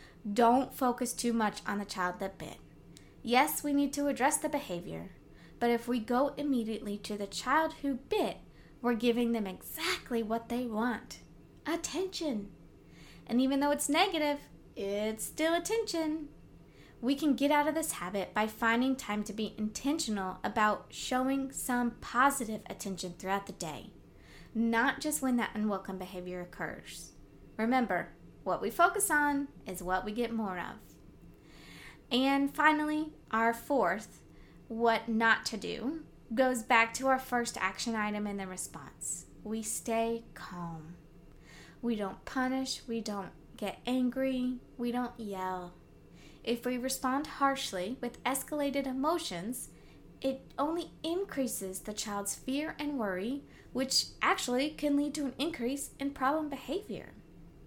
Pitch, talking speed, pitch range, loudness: 245 Hz, 145 wpm, 210-280 Hz, -33 LUFS